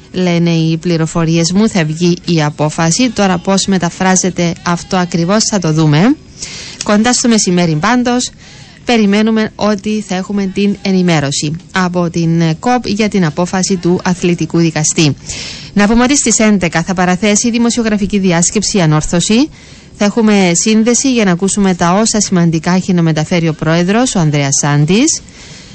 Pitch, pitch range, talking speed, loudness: 185 Hz, 170-210 Hz, 145 wpm, -12 LUFS